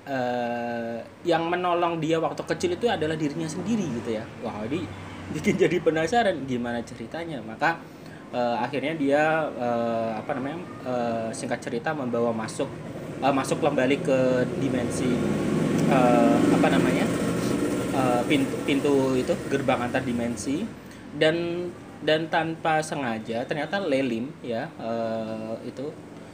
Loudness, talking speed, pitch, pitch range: -26 LUFS, 125 wpm, 135 Hz, 120-160 Hz